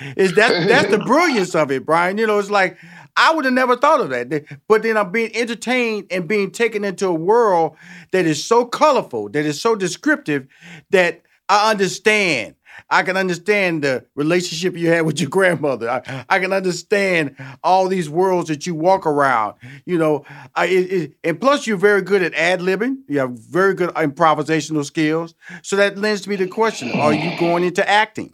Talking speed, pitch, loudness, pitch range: 195 wpm, 185 Hz, -18 LUFS, 160-205 Hz